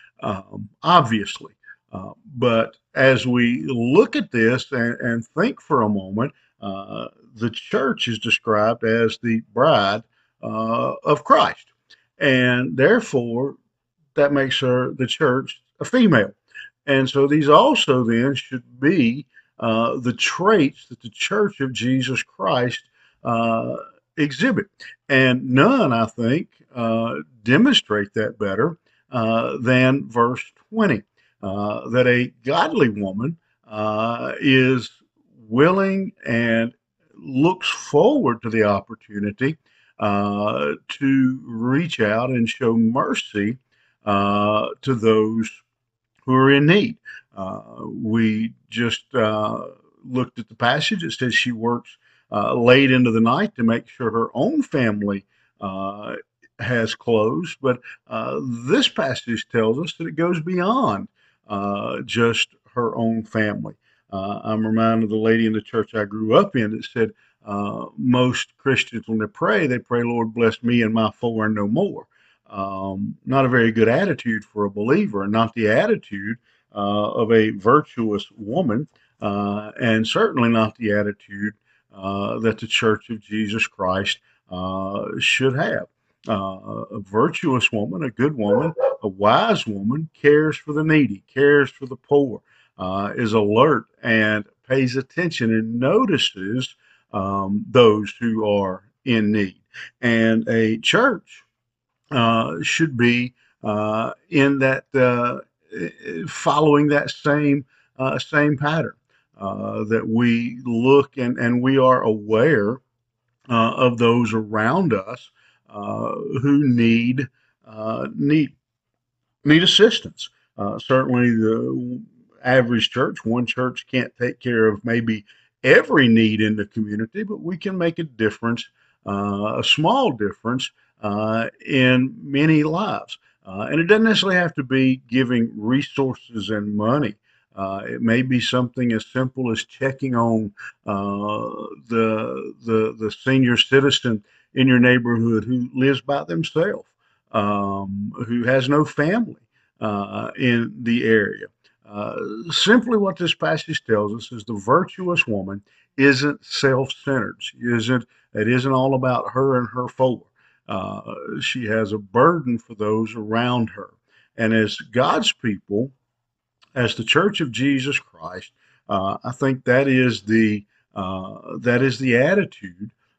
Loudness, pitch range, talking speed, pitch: -20 LUFS, 110-135 Hz, 135 wpm, 120 Hz